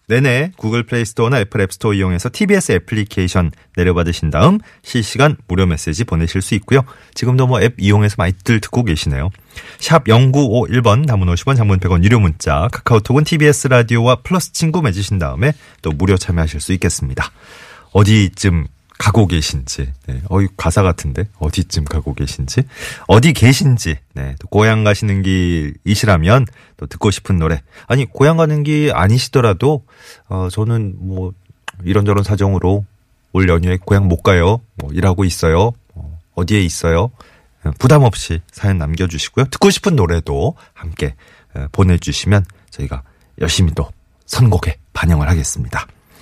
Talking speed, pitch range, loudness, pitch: 335 characters per minute, 85-120 Hz, -15 LUFS, 100 Hz